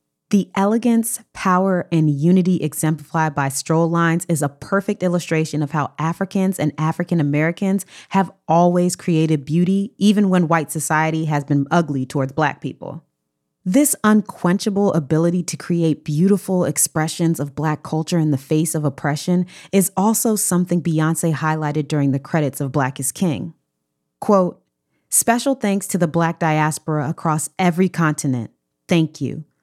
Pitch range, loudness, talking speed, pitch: 150-185 Hz, -19 LUFS, 145 wpm, 165 Hz